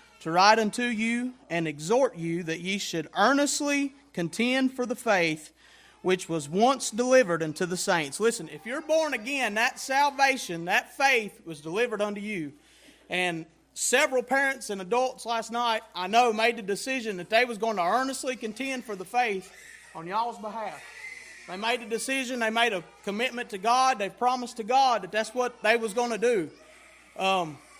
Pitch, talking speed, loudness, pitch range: 230 Hz, 180 wpm, -27 LUFS, 190-255 Hz